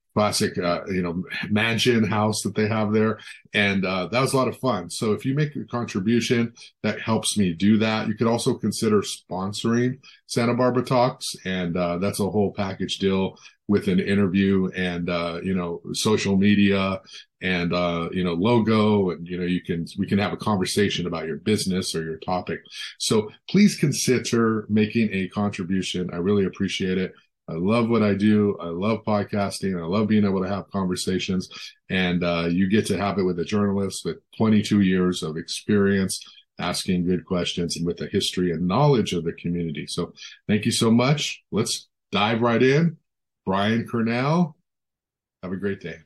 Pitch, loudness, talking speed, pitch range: 100 Hz, -23 LUFS, 185 wpm, 90-115 Hz